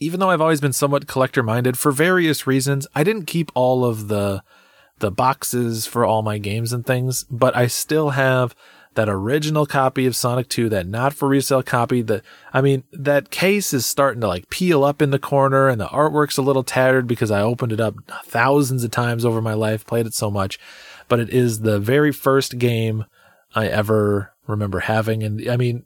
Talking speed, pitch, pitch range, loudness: 205 wpm, 125 Hz, 110-140 Hz, -19 LUFS